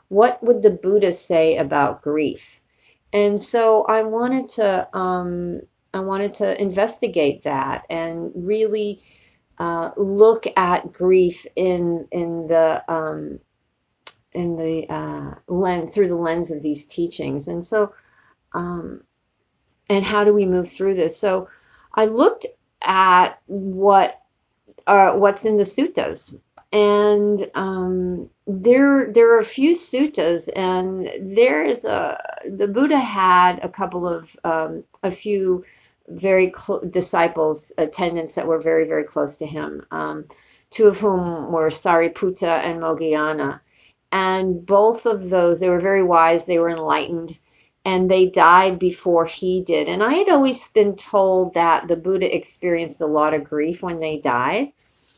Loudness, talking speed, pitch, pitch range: -19 LUFS, 145 wpm, 185 Hz, 165-205 Hz